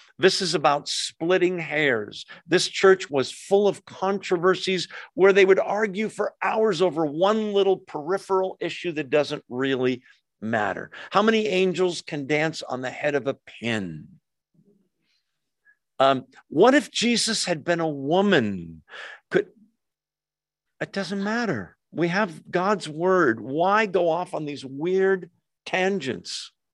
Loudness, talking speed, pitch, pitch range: -23 LUFS, 135 wpm, 185 Hz, 150-195 Hz